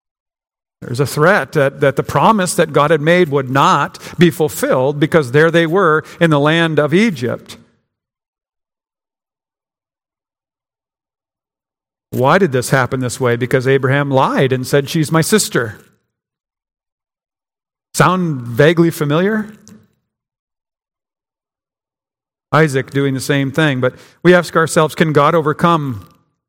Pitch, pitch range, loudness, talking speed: 150 Hz, 135-165 Hz, -14 LUFS, 120 wpm